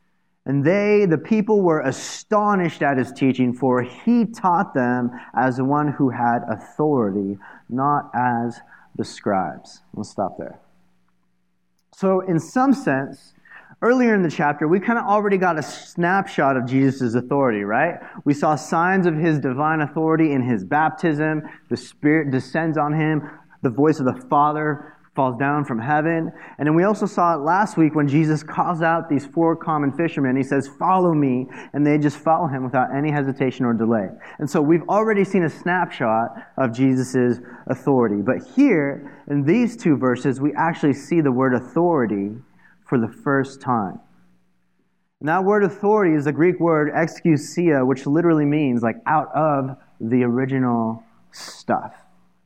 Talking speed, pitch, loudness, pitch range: 160 wpm, 145 Hz, -20 LUFS, 130-165 Hz